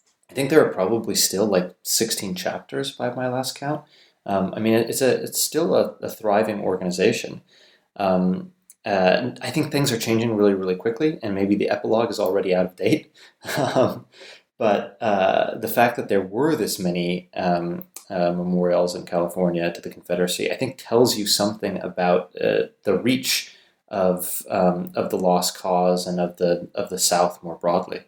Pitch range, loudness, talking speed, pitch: 90-115 Hz, -22 LUFS, 175 wpm, 95 Hz